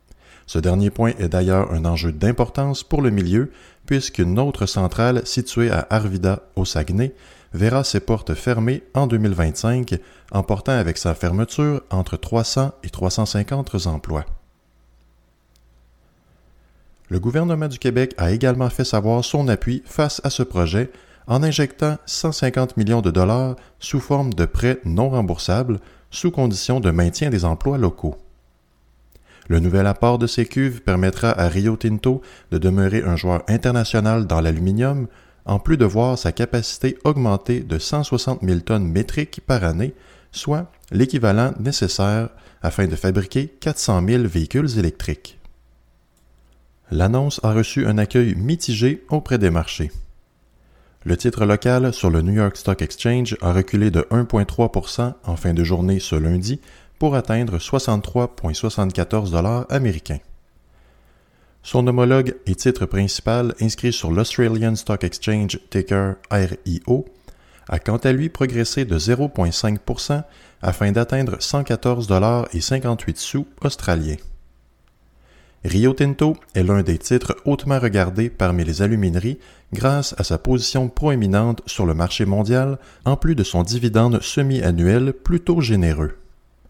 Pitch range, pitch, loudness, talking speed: 90-125 Hz, 110 Hz, -20 LUFS, 135 wpm